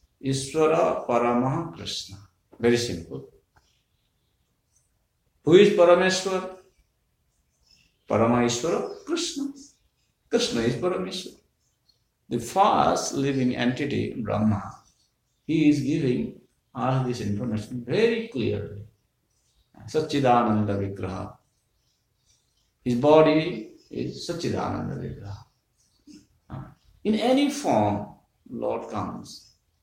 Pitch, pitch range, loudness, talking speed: 125 Hz, 105-160 Hz, -24 LUFS, 70 wpm